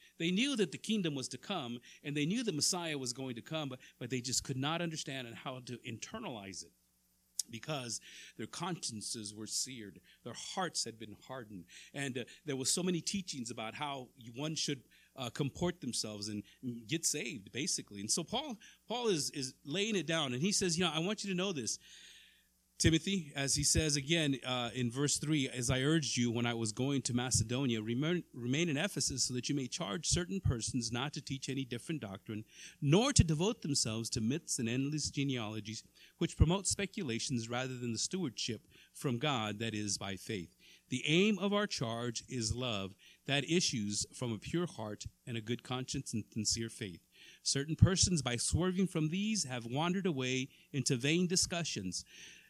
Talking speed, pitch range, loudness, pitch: 190 wpm, 115-160 Hz, -36 LUFS, 130 Hz